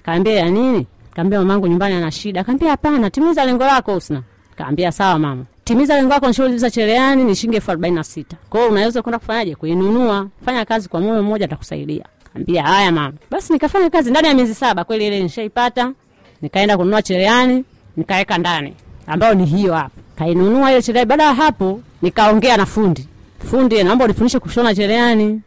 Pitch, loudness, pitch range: 210 Hz, -15 LUFS, 175-245 Hz